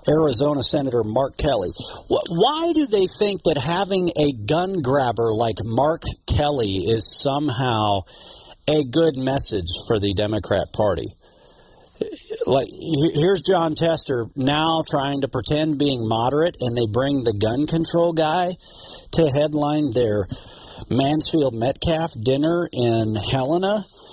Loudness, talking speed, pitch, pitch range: -20 LUFS, 125 wpm, 145 Hz, 120-165 Hz